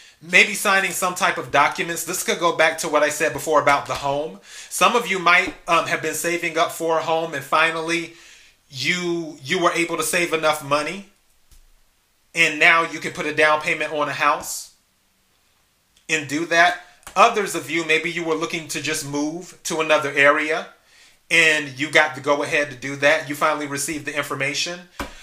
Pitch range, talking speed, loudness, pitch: 145-170 Hz, 195 wpm, -19 LUFS, 160 Hz